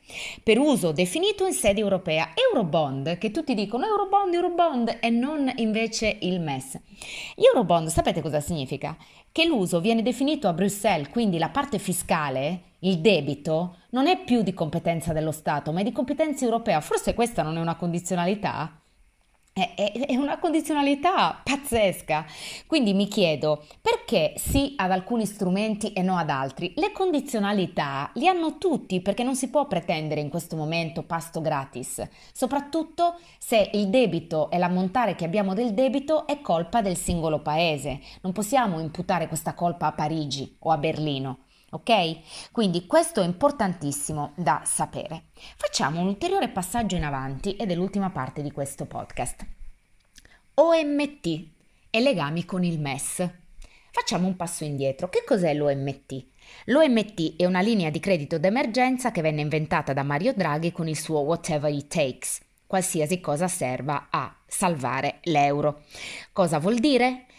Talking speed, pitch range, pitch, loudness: 150 wpm, 160-240 Hz, 185 Hz, -25 LUFS